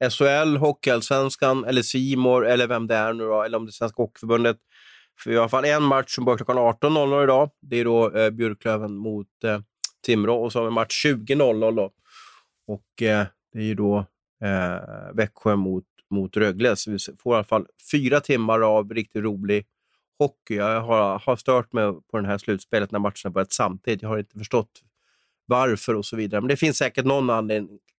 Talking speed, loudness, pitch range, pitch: 205 wpm, -23 LUFS, 105-125 Hz, 115 Hz